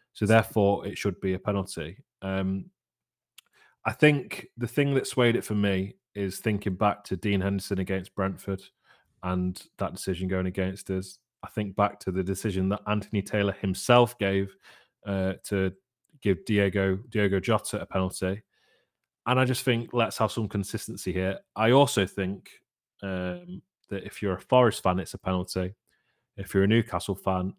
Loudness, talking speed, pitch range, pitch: -27 LUFS, 165 wpm, 95-110 Hz, 100 Hz